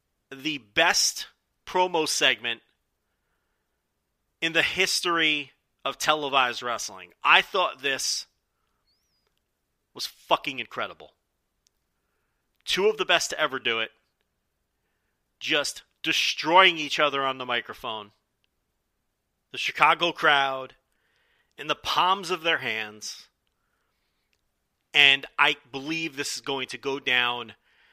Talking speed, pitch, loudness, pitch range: 105 wpm, 135 Hz, -24 LUFS, 110-160 Hz